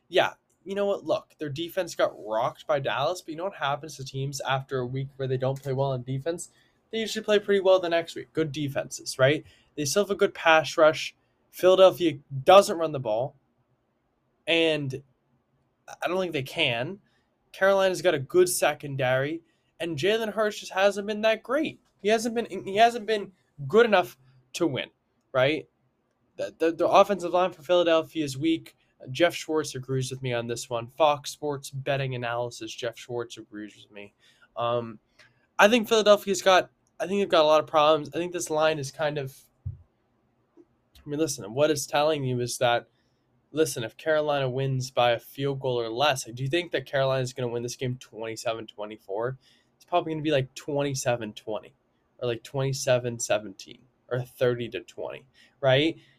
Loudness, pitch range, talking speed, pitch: -26 LUFS, 125-175 Hz, 185 wpm, 145 Hz